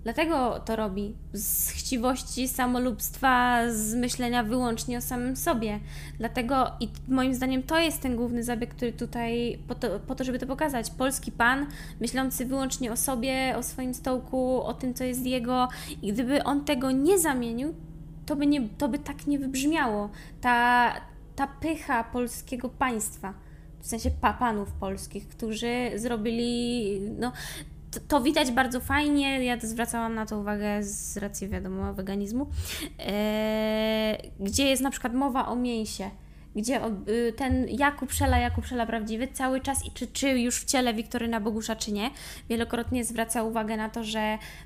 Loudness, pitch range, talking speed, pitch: -28 LUFS, 225-260 Hz, 160 wpm, 245 Hz